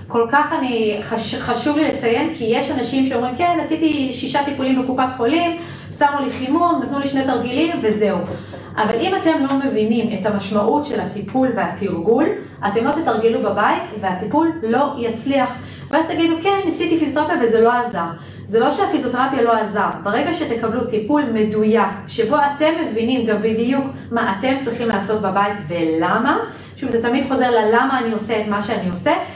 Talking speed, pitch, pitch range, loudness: 165 wpm, 245 Hz, 220-285 Hz, -18 LUFS